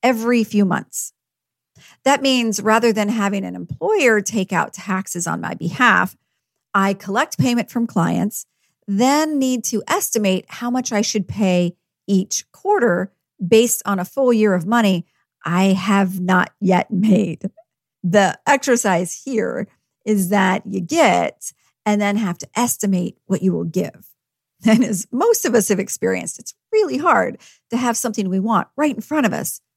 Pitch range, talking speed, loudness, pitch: 190-235 Hz, 160 wpm, -18 LUFS, 210 Hz